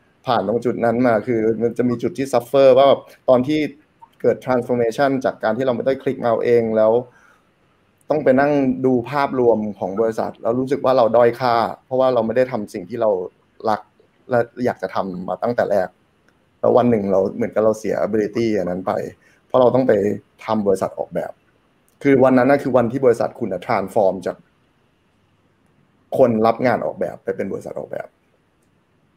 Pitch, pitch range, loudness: 120 Hz, 115-130 Hz, -19 LUFS